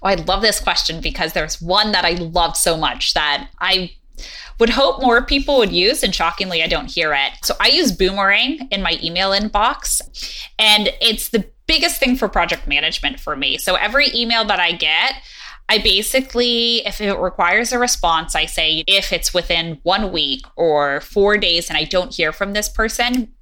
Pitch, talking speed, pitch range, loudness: 195 Hz, 190 wpm, 165-235 Hz, -16 LUFS